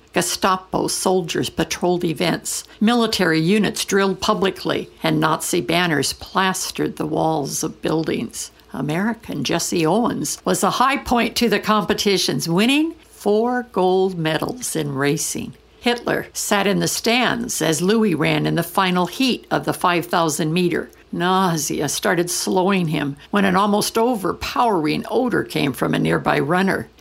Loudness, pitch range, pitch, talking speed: -19 LUFS, 170-215 Hz, 185 Hz, 140 wpm